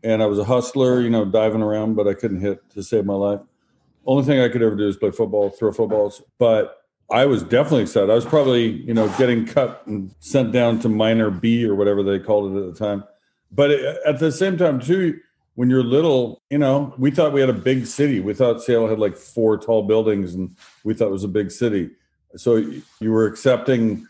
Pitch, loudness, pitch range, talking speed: 110 Hz, -19 LUFS, 105-130 Hz, 230 wpm